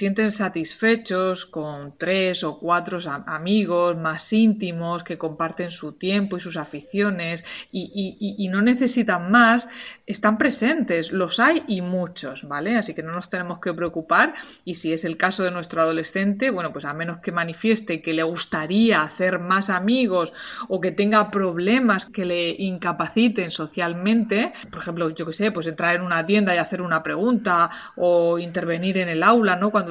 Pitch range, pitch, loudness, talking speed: 170-205 Hz, 180 Hz, -22 LUFS, 170 wpm